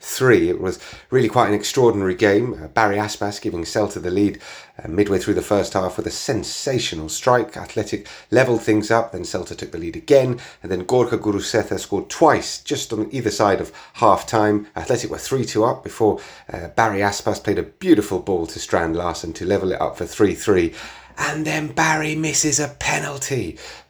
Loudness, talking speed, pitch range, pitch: -20 LUFS, 190 wpm, 100-125 Hz, 105 Hz